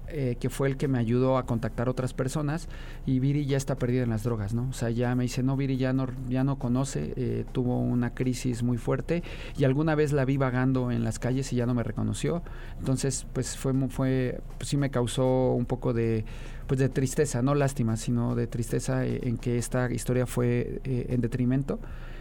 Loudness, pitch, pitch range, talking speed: -28 LUFS, 130 Hz, 120-135 Hz, 215 wpm